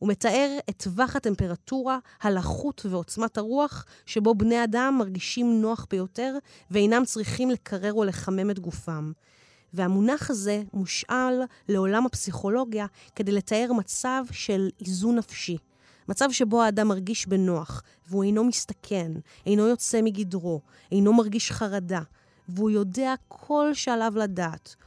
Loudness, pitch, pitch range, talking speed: -26 LUFS, 215 Hz, 190-240 Hz, 125 wpm